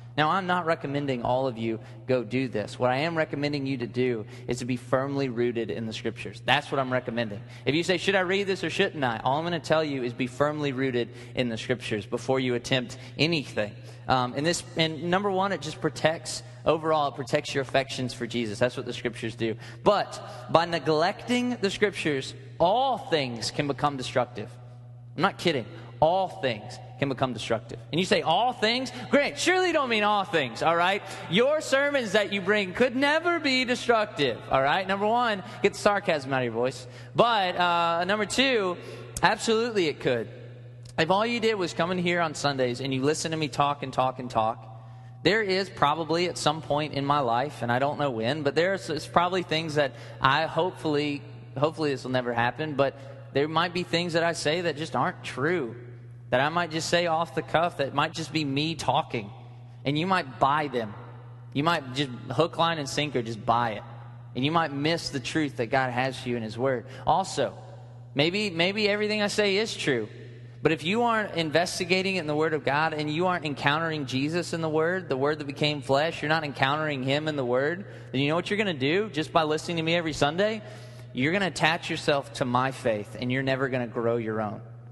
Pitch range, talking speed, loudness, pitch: 125-170 Hz, 215 wpm, -26 LUFS, 145 Hz